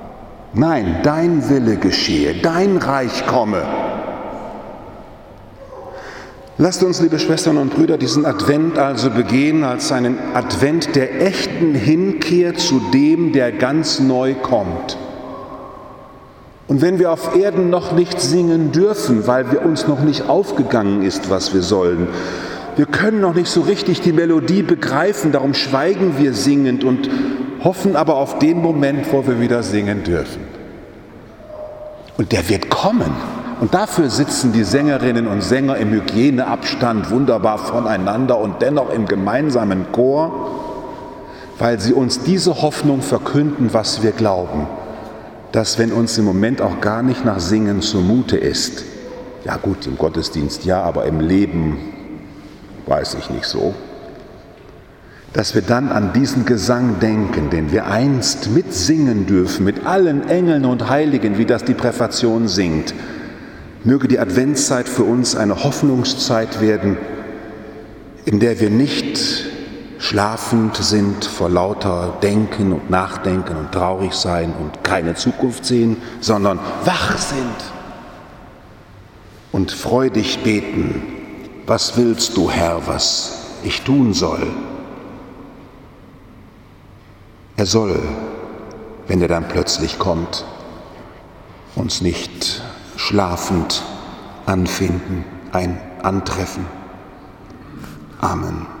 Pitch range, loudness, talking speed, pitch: 100-145 Hz, -17 LUFS, 120 wpm, 120 Hz